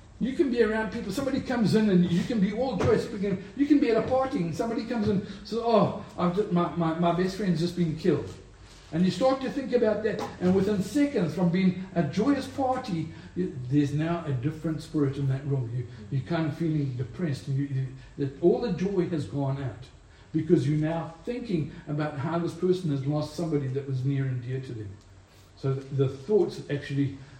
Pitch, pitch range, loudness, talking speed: 170 Hz, 140-210 Hz, -28 LUFS, 210 wpm